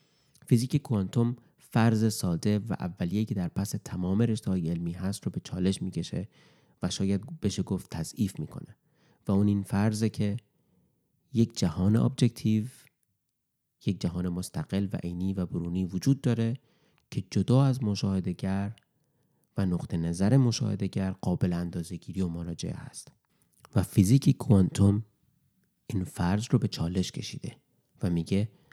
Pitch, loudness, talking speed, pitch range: 100 Hz, -29 LUFS, 135 wpm, 95-120 Hz